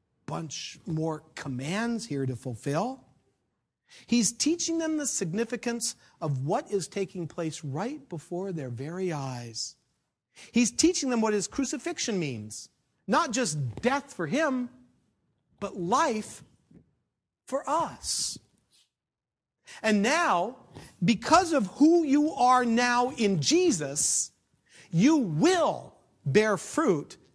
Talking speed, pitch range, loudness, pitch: 110 wpm, 165-275 Hz, -27 LUFS, 225 Hz